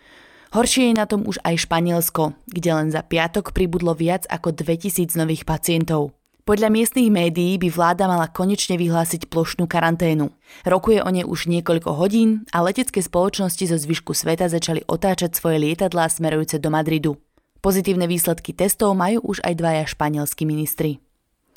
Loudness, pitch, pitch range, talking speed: -20 LUFS, 170 Hz, 160-190 Hz, 155 wpm